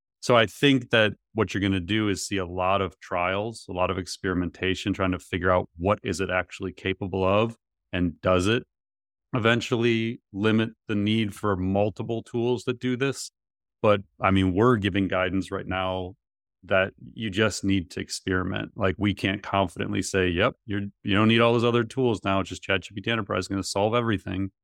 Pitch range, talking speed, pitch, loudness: 95-110 Hz, 195 wpm, 100 Hz, -25 LUFS